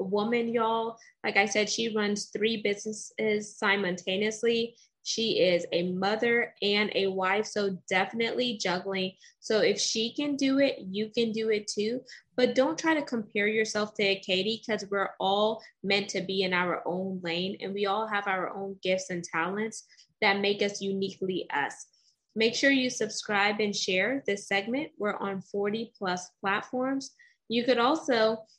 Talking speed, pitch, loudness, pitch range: 165 wpm, 210 Hz, -28 LUFS, 195-230 Hz